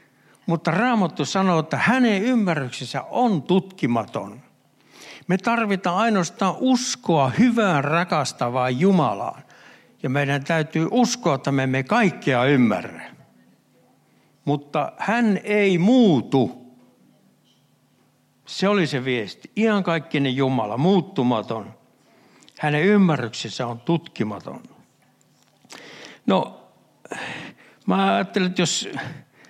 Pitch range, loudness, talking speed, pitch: 135-205 Hz, -21 LUFS, 90 wpm, 170 Hz